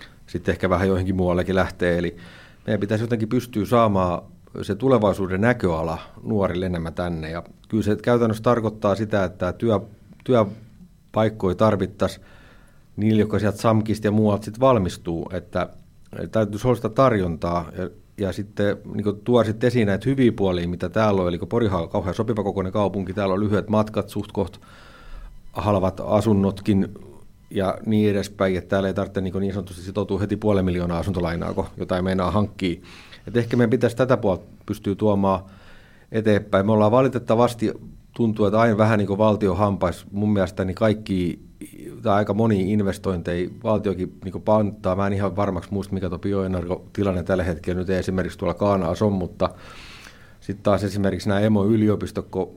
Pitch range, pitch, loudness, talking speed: 95-110 Hz, 100 Hz, -22 LUFS, 160 wpm